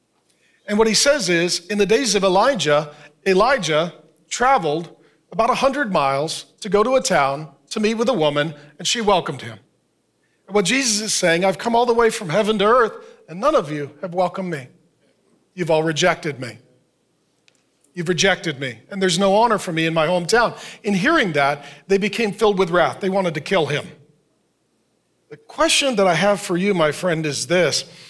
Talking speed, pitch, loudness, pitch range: 190 wpm, 185 Hz, -19 LUFS, 155-215 Hz